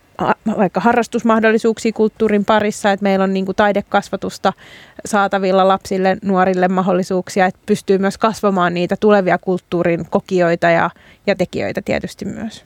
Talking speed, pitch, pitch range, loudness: 125 wpm, 195 Hz, 185-215 Hz, -16 LUFS